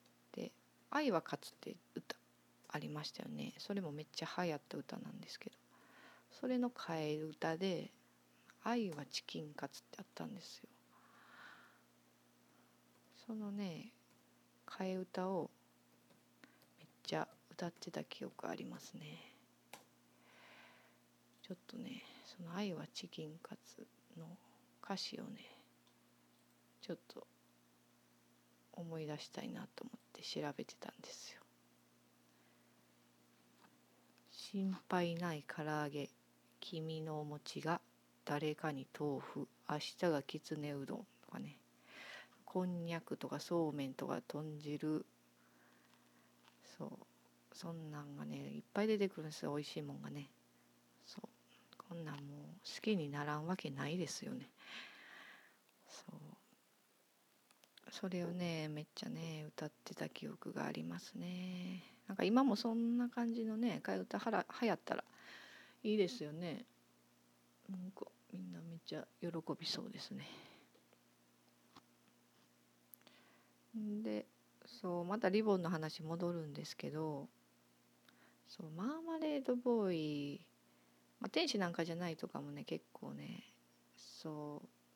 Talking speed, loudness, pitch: 225 characters per minute, -44 LUFS, 140 Hz